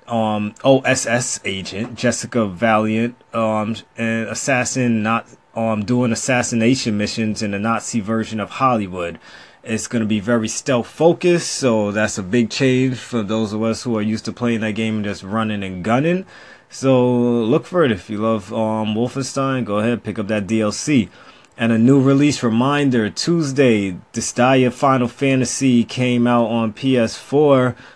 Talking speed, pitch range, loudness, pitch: 160 wpm, 110-125 Hz, -18 LUFS, 115 Hz